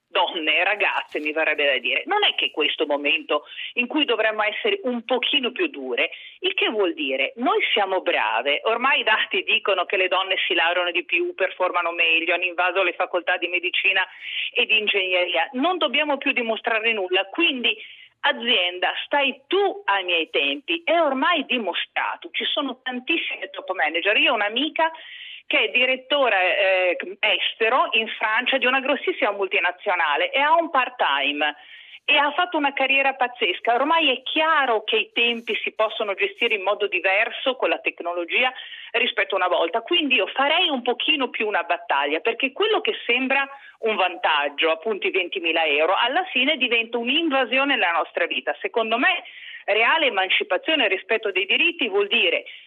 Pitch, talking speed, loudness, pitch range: 245 Hz, 170 wpm, -21 LUFS, 185-310 Hz